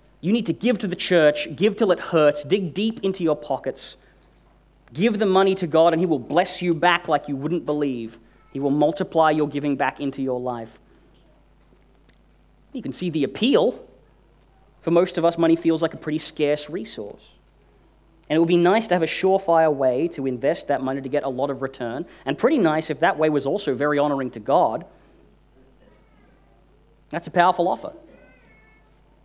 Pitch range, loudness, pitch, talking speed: 140-175 Hz, -22 LUFS, 155 Hz, 190 wpm